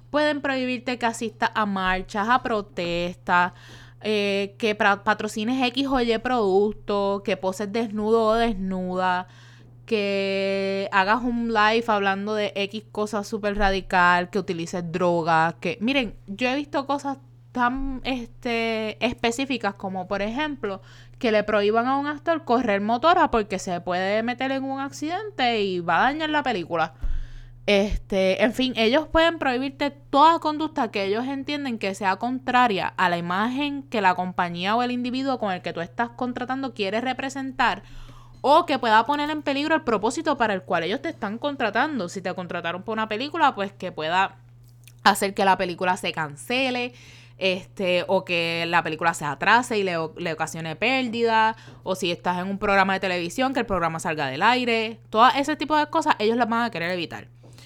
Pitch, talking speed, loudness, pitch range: 210 Hz, 170 wpm, -23 LUFS, 180-250 Hz